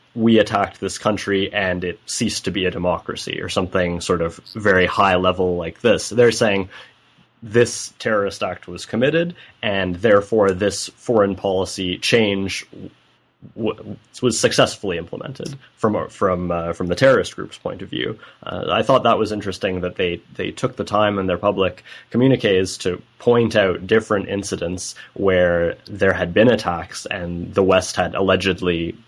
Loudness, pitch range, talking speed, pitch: -19 LUFS, 90-110 Hz, 160 wpm, 95 Hz